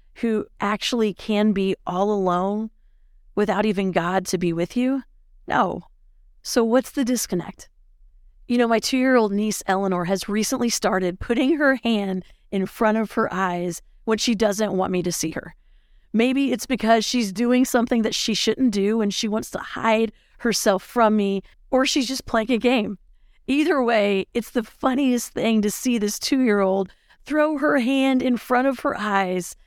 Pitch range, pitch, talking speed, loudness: 195-250 Hz, 220 Hz, 180 wpm, -22 LUFS